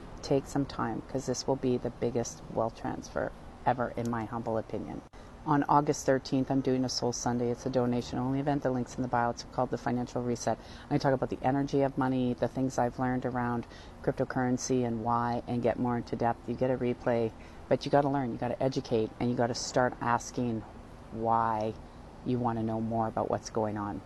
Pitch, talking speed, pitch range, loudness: 120 Hz, 220 wpm, 115-130 Hz, -31 LUFS